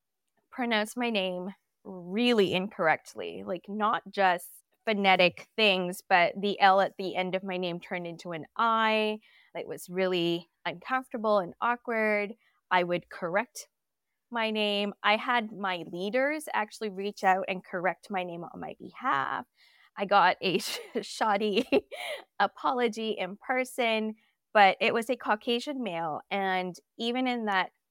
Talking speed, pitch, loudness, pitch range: 140 wpm, 205 Hz, -28 LUFS, 185-225 Hz